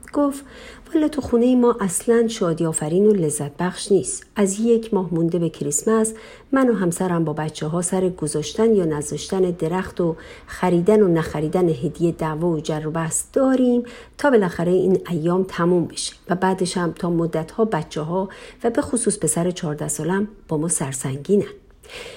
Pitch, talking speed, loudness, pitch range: 180 Hz, 175 wpm, -21 LUFS, 160-220 Hz